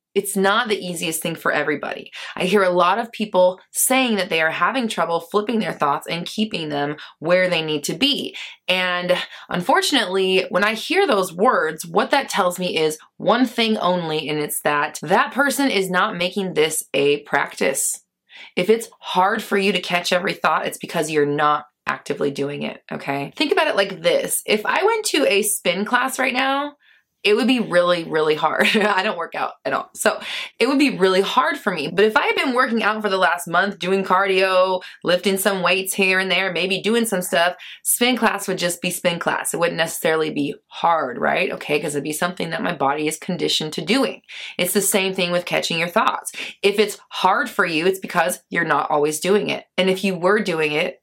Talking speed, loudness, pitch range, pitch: 215 wpm, -20 LUFS, 170-215 Hz, 185 Hz